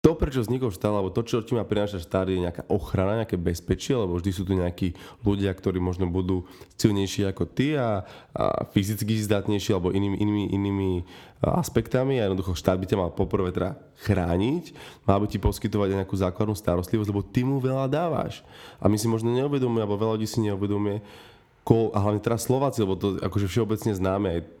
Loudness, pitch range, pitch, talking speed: -26 LUFS, 95-115 Hz, 105 Hz, 195 wpm